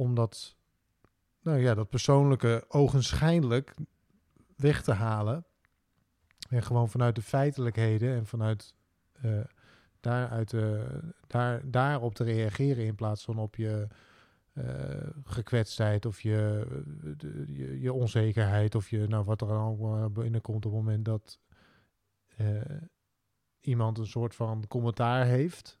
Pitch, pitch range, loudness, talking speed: 115 Hz, 105-125 Hz, -30 LUFS, 130 wpm